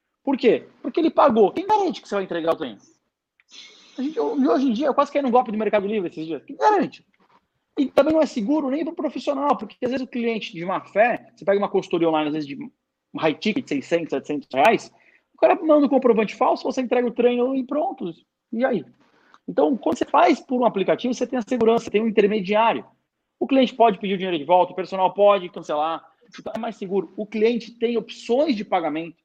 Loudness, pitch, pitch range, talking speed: -22 LUFS, 230 Hz, 200-275 Hz, 230 wpm